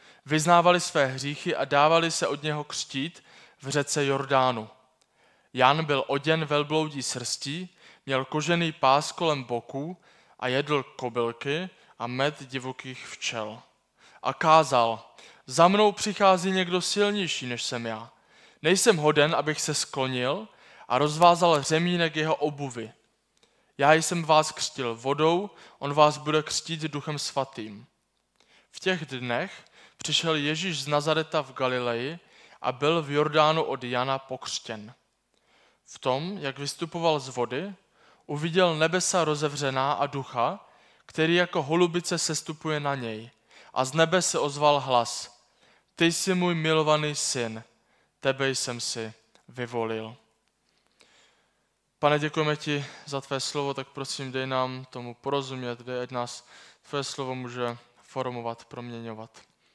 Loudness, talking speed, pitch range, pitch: -26 LUFS, 130 wpm, 130-160 Hz, 145 Hz